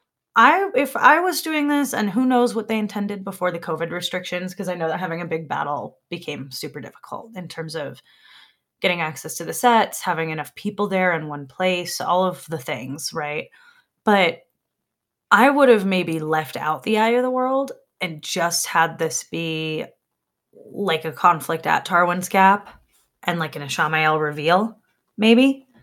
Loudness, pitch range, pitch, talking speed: -21 LUFS, 160-215 Hz, 180 Hz, 175 wpm